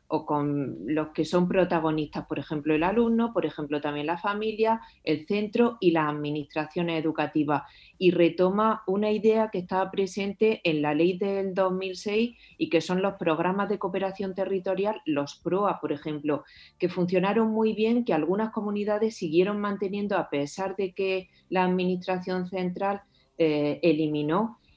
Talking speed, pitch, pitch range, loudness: 155 wpm, 185 Hz, 155-205 Hz, -27 LUFS